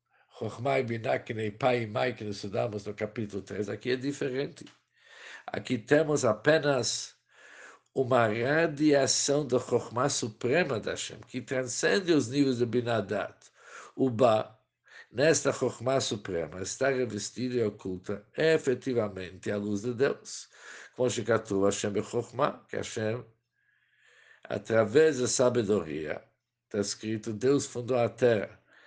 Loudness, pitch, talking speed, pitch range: -29 LUFS, 120 Hz, 125 wpm, 105-130 Hz